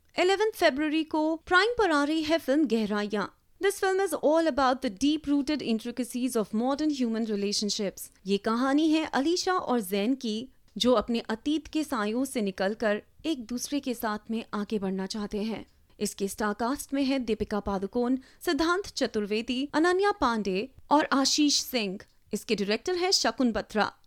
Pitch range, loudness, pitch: 215-305 Hz, -28 LUFS, 250 Hz